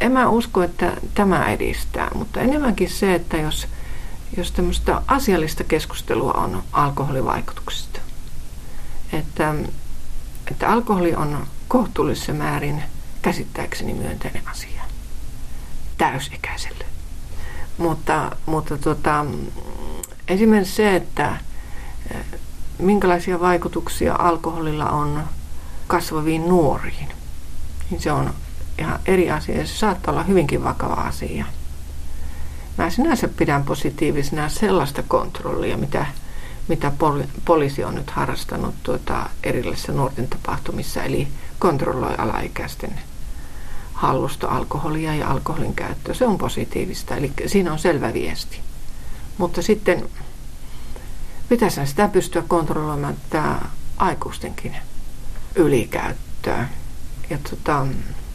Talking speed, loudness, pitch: 100 wpm, -22 LUFS, 150 Hz